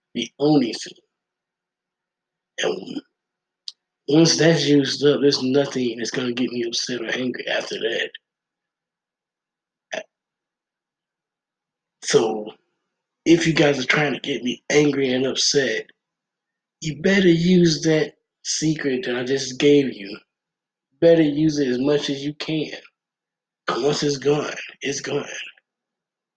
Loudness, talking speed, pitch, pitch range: -20 LUFS, 125 wpm, 145 Hz, 130-165 Hz